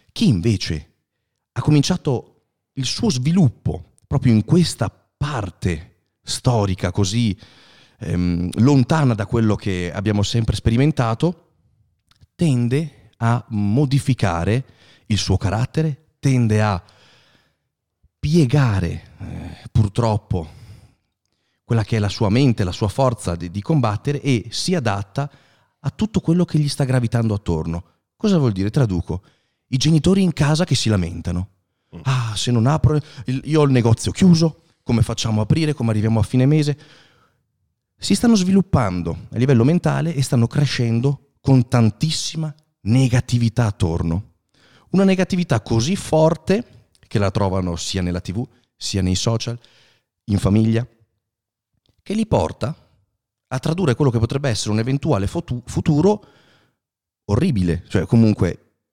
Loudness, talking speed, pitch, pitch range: -19 LUFS, 130 wpm, 120 Hz, 105-140 Hz